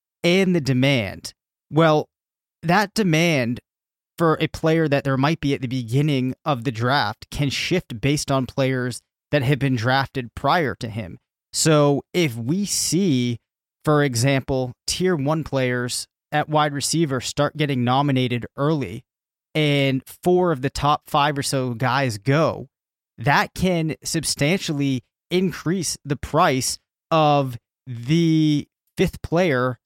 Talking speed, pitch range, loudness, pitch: 135 wpm, 125-155 Hz, -21 LUFS, 140 Hz